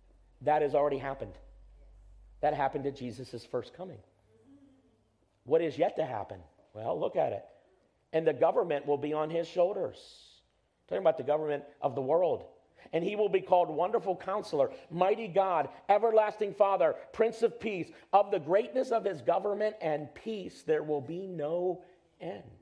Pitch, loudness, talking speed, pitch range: 180 Hz, -31 LUFS, 165 wpm, 150-210 Hz